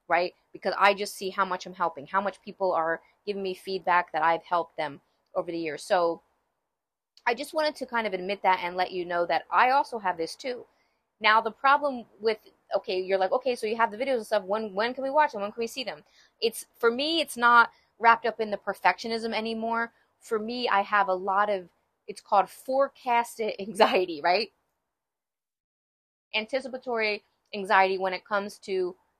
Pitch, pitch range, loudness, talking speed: 210 Hz, 185-235 Hz, -27 LUFS, 200 wpm